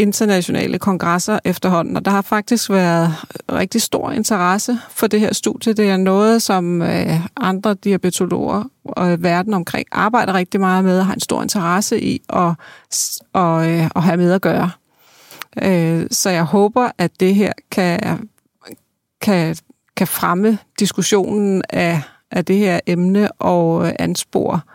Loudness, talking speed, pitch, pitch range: -17 LUFS, 145 wpm, 190 Hz, 175-210 Hz